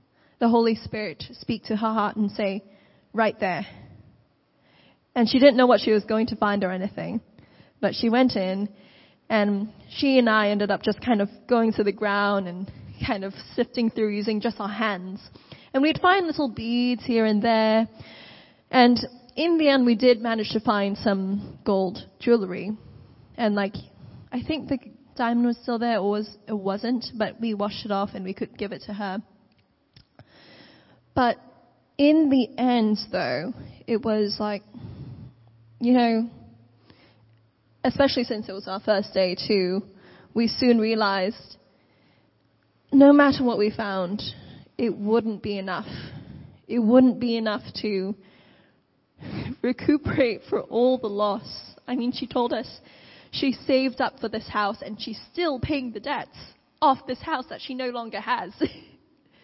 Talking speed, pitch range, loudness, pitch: 160 wpm, 200-245 Hz, -24 LUFS, 220 Hz